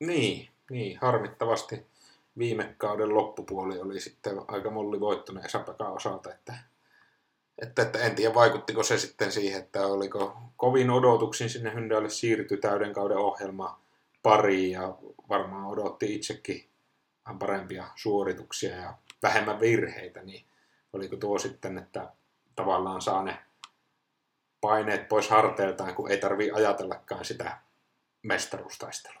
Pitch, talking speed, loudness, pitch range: 105 Hz, 120 wpm, -29 LUFS, 95-115 Hz